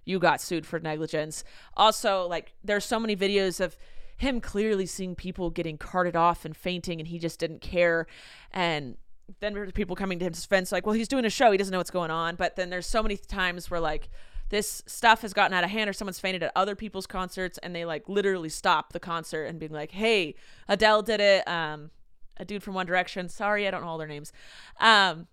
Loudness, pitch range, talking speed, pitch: -27 LUFS, 170-205 Hz, 225 wpm, 185 Hz